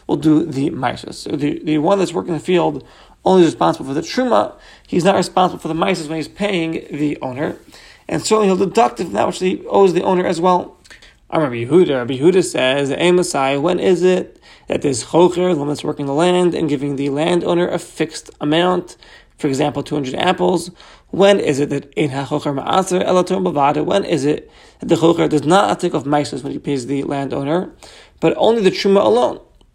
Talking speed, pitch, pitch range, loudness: 200 wpm, 170 Hz, 150-185 Hz, -17 LUFS